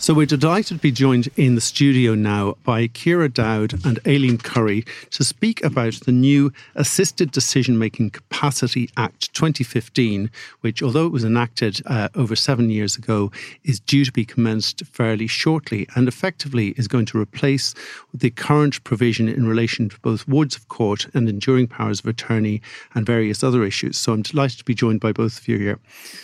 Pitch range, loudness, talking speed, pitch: 110-140 Hz, -20 LUFS, 185 wpm, 120 Hz